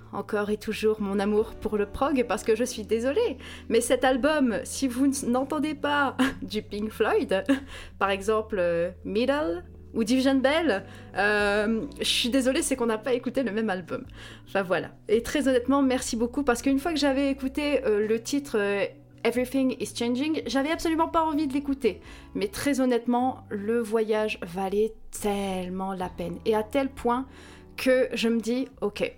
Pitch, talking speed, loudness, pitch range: 240 Hz, 175 wpm, -26 LUFS, 210-270 Hz